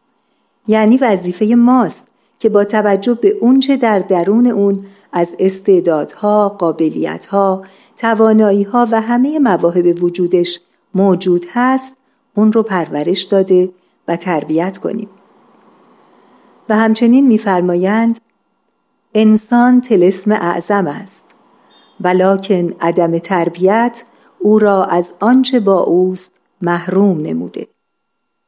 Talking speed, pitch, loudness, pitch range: 95 wpm, 200 Hz, -13 LUFS, 180-225 Hz